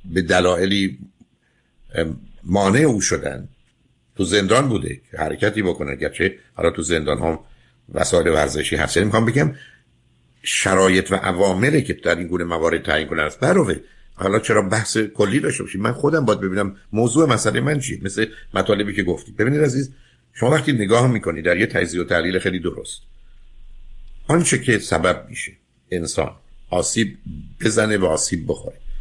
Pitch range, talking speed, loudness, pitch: 90-120 Hz, 150 wpm, -19 LUFS, 100 Hz